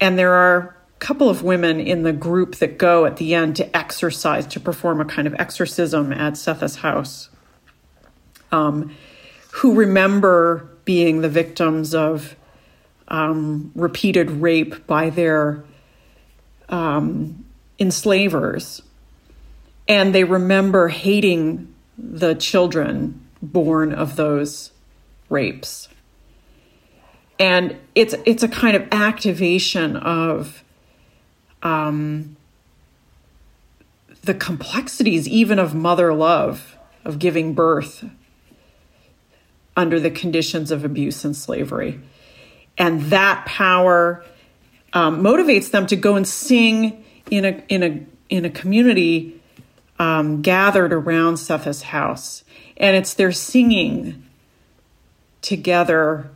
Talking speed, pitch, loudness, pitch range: 110 wpm, 170 Hz, -18 LUFS, 155-190 Hz